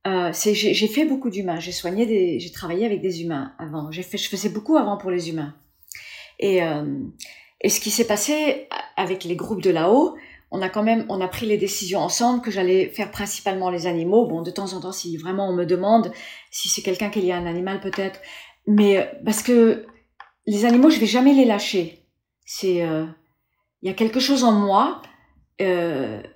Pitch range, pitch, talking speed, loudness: 180-225 Hz, 195 Hz, 210 wpm, -21 LUFS